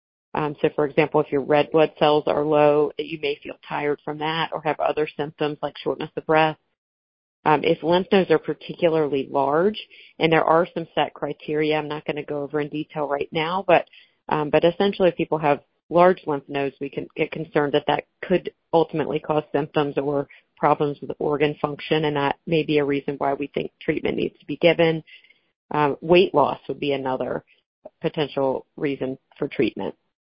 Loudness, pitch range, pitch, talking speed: -23 LUFS, 145-160 Hz, 150 Hz, 190 wpm